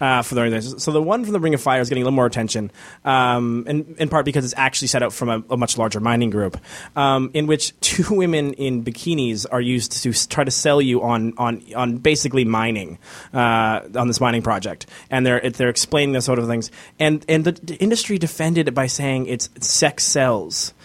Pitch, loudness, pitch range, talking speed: 125 Hz, -19 LUFS, 120-150 Hz, 215 wpm